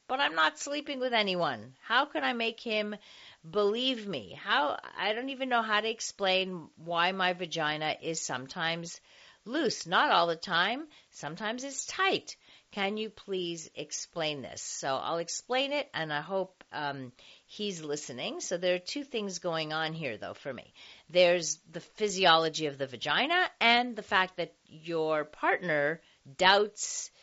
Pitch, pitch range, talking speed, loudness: 180 Hz, 160-225 Hz, 160 wpm, -30 LUFS